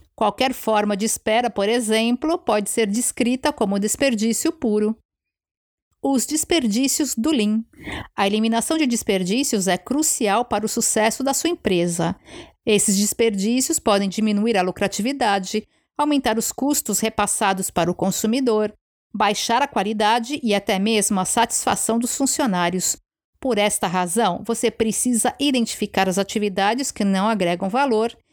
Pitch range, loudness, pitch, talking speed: 205-250 Hz, -20 LUFS, 225 Hz, 135 wpm